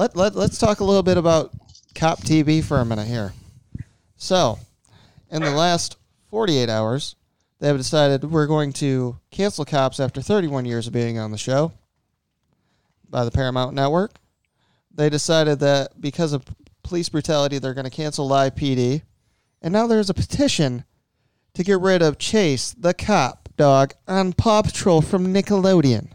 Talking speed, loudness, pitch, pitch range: 165 wpm, -20 LUFS, 145 Hz, 125-170 Hz